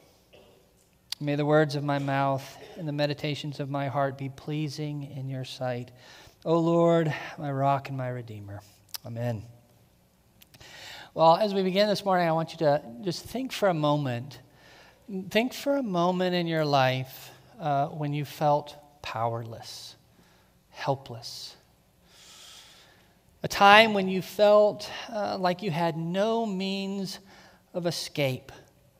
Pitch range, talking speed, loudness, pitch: 130-180 Hz, 135 wpm, -27 LUFS, 145 Hz